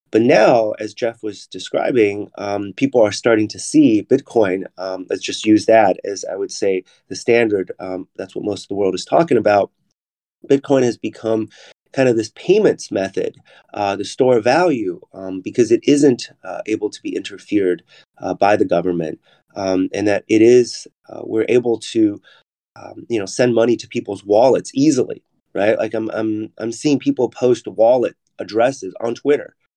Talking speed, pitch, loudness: 180 wpm, 120 Hz, -17 LUFS